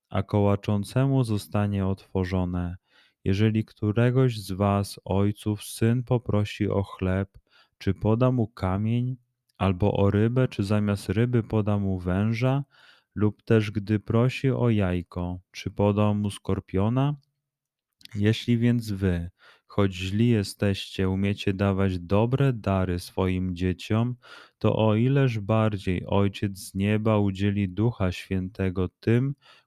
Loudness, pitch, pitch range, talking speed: -26 LUFS, 105 Hz, 95-115 Hz, 120 wpm